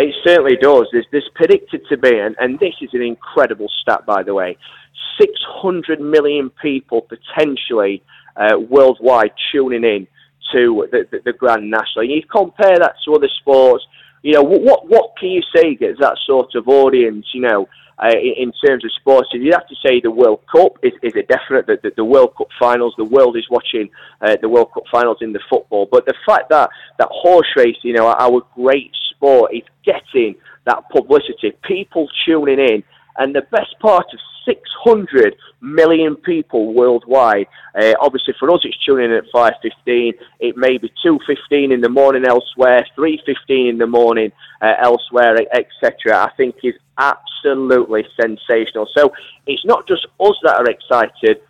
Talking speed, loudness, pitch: 175 wpm, -14 LUFS, 155 Hz